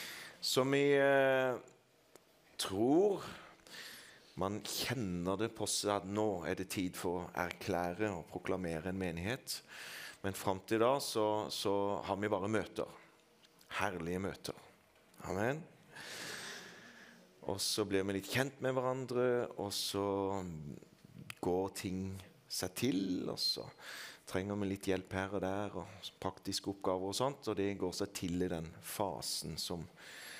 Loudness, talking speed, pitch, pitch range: -37 LUFS, 140 wpm, 100 Hz, 95-110 Hz